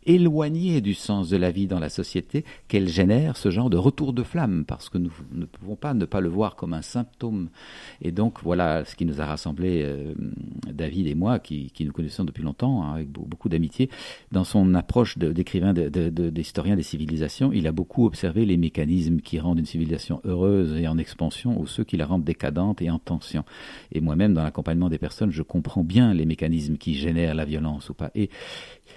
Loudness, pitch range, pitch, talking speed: -25 LUFS, 80-100 Hz, 85 Hz, 215 wpm